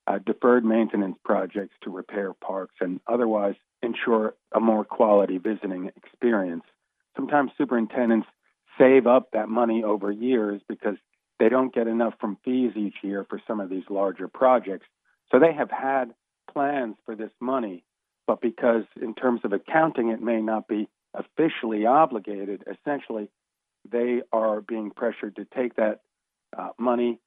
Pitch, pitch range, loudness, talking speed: 115 Hz, 105-125 Hz, -25 LUFS, 150 wpm